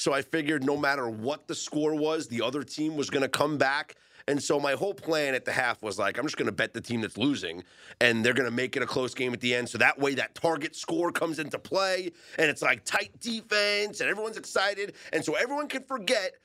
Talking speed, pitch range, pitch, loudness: 245 wpm, 125-190 Hz, 150 Hz, -28 LUFS